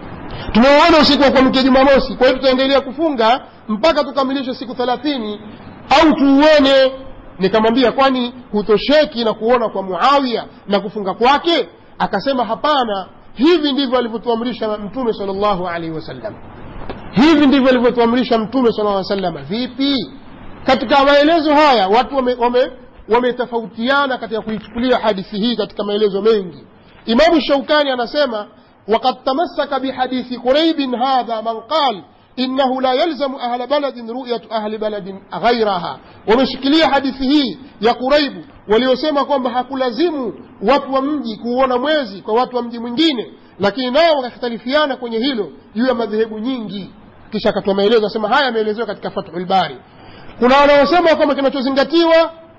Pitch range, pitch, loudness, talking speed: 220-275 Hz, 250 Hz, -15 LUFS, 125 wpm